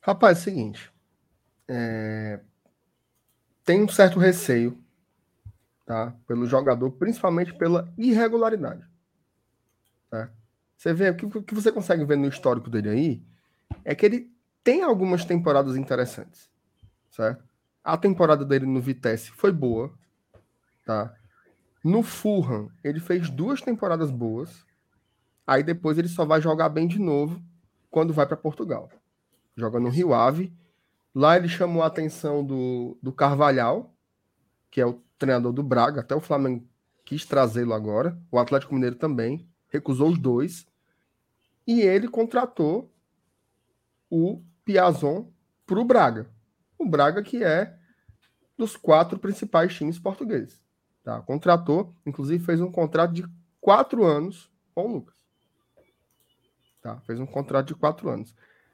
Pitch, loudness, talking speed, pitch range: 145 Hz, -24 LUFS, 135 wpm, 120-175 Hz